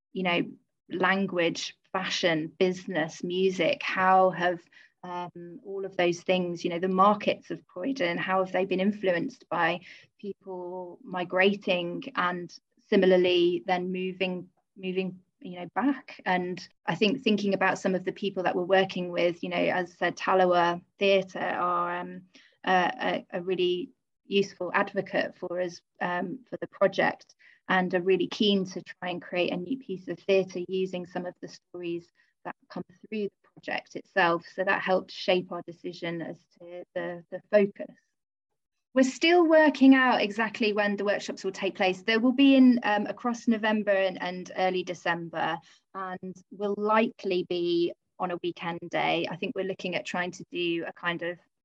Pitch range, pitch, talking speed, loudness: 175-200 Hz, 185 Hz, 165 wpm, -27 LUFS